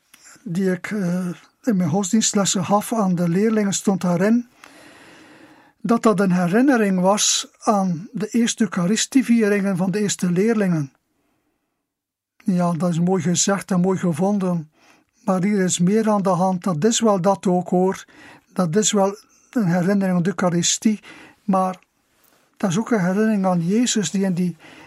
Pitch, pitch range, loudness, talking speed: 200 Hz, 185-220 Hz, -20 LUFS, 155 wpm